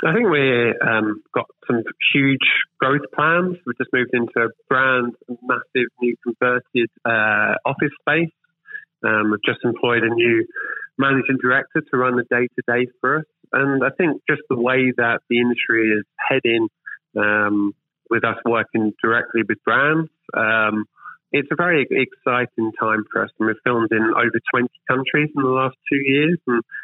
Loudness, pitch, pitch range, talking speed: -19 LUFS, 125 Hz, 115-135 Hz, 170 wpm